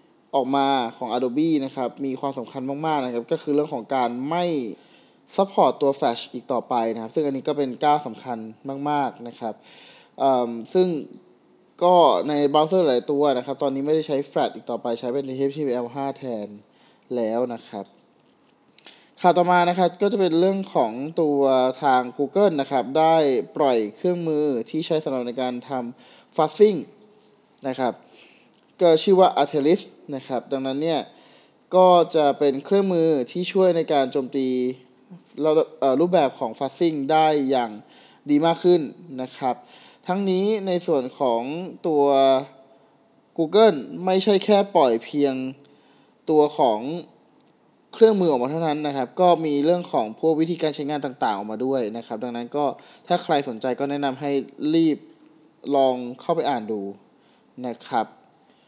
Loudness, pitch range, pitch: -22 LUFS, 130-175 Hz, 145 Hz